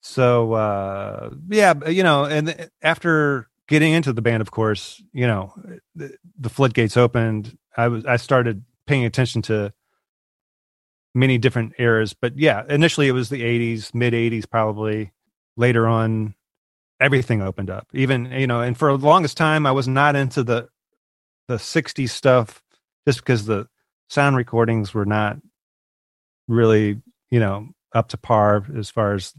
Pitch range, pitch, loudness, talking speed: 110-140 Hz, 120 Hz, -20 LUFS, 155 wpm